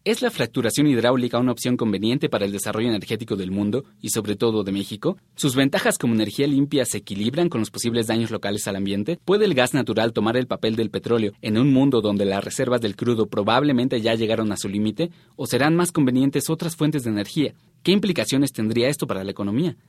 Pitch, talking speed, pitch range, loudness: 120 Hz, 210 wpm, 105-140 Hz, -22 LUFS